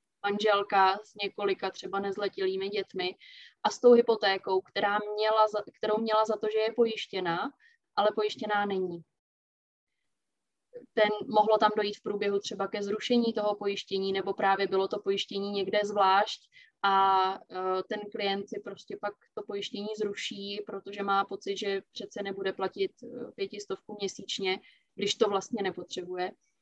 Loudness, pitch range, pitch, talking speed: -30 LUFS, 195-215 Hz, 205 Hz, 135 wpm